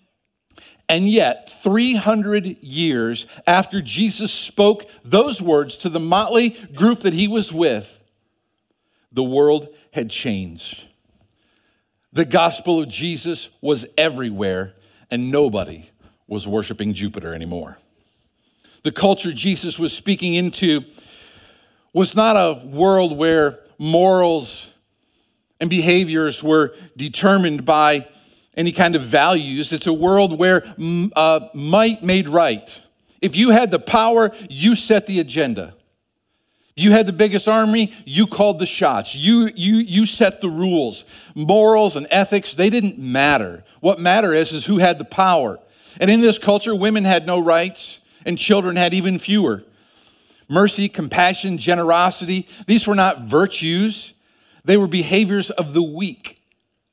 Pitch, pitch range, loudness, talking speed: 175 Hz, 150-205 Hz, -17 LUFS, 135 wpm